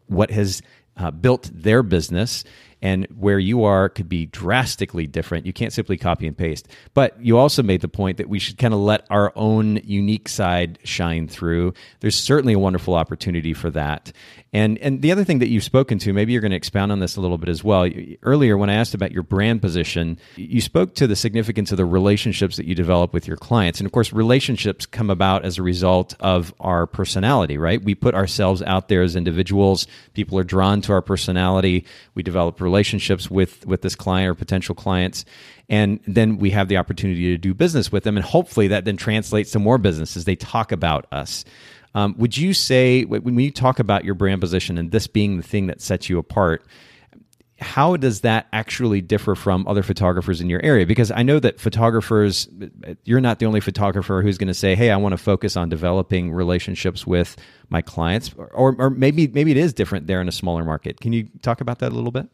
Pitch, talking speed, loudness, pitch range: 100 Hz, 215 wpm, -20 LUFS, 90-110 Hz